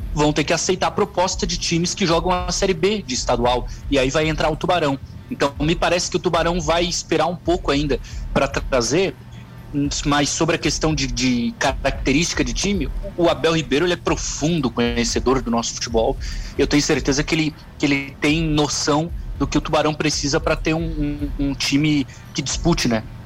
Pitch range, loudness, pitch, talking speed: 135-165 Hz, -20 LUFS, 150 Hz, 195 wpm